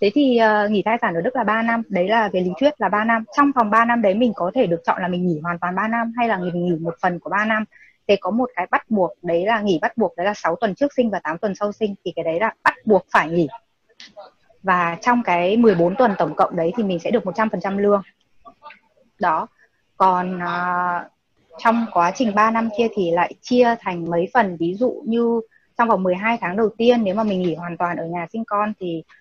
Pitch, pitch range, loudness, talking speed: 205 Hz, 175-230 Hz, -20 LUFS, 255 wpm